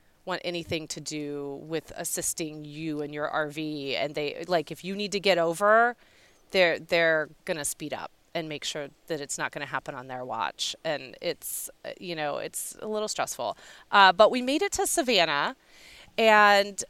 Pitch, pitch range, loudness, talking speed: 165 Hz, 150-200 Hz, -27 LUFS, 180 wpm